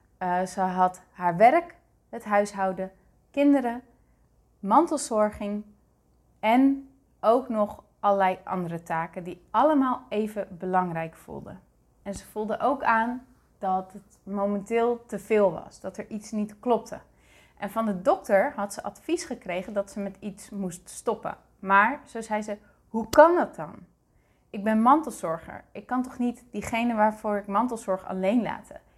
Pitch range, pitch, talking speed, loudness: 195-235 Hz, 210 Hz, 145 wpm, -26 LUFS